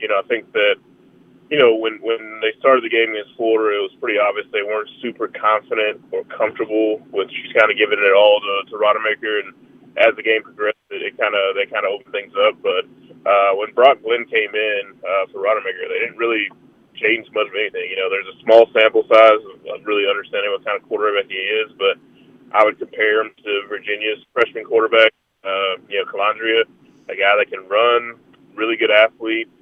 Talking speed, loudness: 210 wpm, -17 LUFS